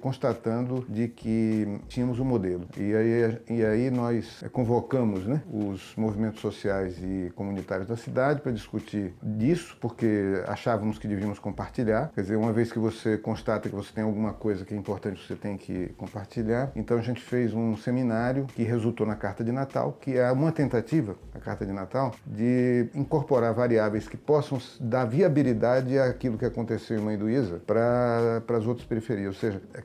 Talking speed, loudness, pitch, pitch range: 175 wpm, -28 LUFS, 115 Hz, 105-125 Hz